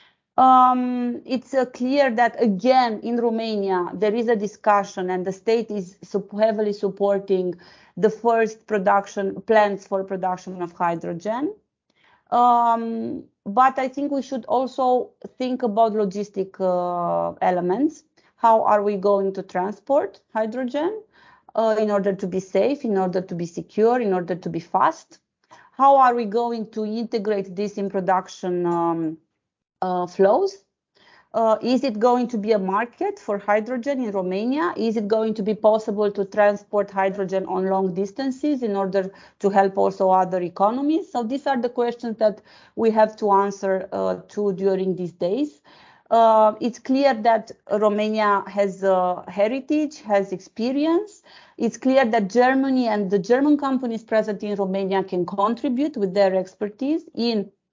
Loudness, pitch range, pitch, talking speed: -22 LUFS, 195-245 Hz, 215 Hz, 155 wpm